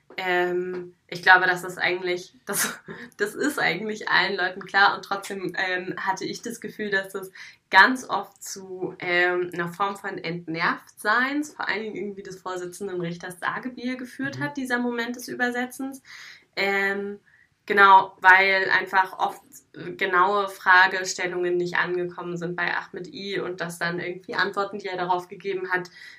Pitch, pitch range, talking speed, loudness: 190 Hz, 180-200 Hz, 160 wpm, -23 LUFS